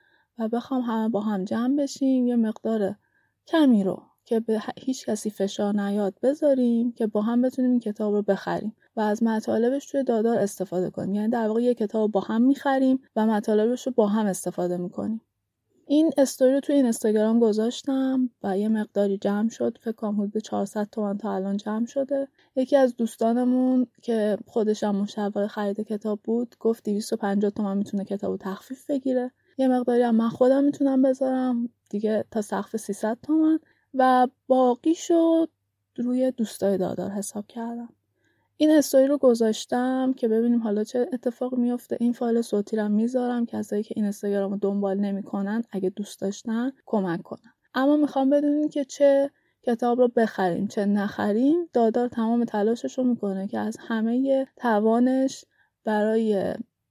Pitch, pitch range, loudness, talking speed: 230 Hz, 210-255 Hz, -24 LUFS, 160 wpm